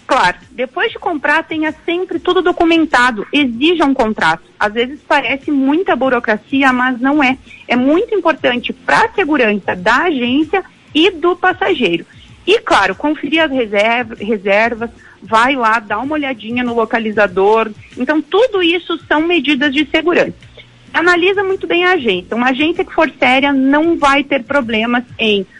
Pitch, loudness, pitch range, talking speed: 285 Hz, -14 LUFS, 240-335 Hz, 150 wpm